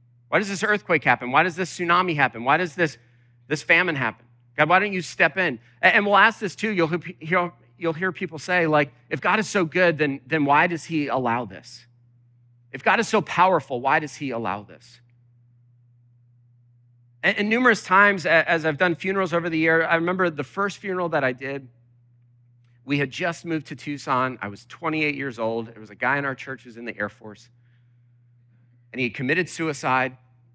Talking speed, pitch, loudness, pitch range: 205 wpm, 140 Hz, -22 LUFS, 120-170 Hz